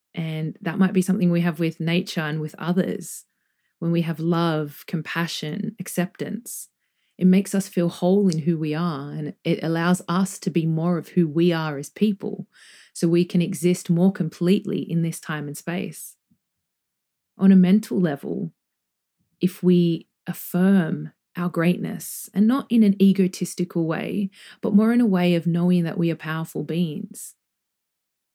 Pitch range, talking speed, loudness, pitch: 165-195 Hz, 165 wpm, -23 LUFS, 175 Hz